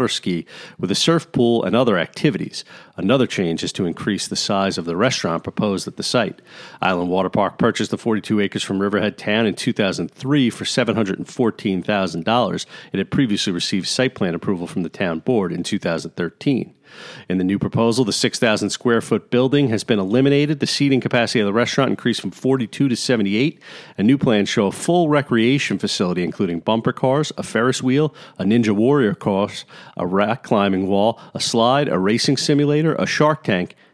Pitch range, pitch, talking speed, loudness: 100-140 Hz, 115 Hz, 185 wpm, -19 LUFS